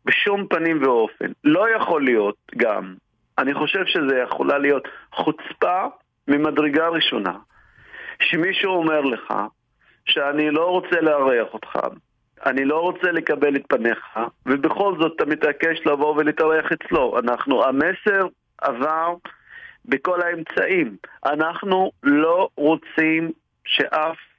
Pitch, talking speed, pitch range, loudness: 165 Hz, 110 wpm, 155-190 Hz, -20 LUFS